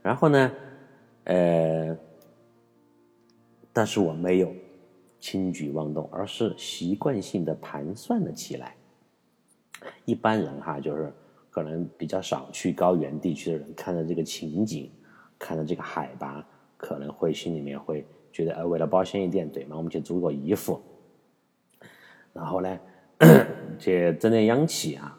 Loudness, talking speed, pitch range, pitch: -26 LUFS, 210 characters per minute, 80-115 Hz, 90 Hz